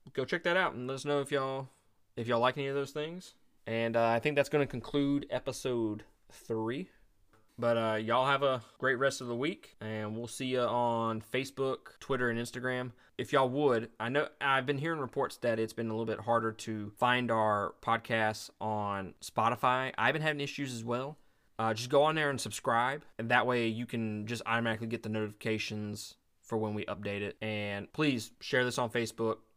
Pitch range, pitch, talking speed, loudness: 110-135 Hz, 120 Hz, 205 wpm, -33 LUFS